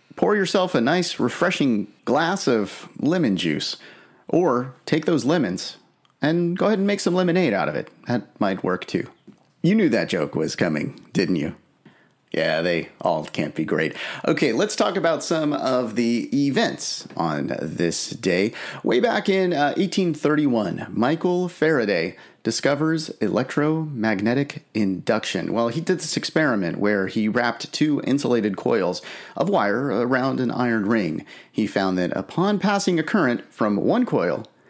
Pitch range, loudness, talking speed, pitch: 120-180 Hz, -22 LUFS, 155 wpm, 150 Hz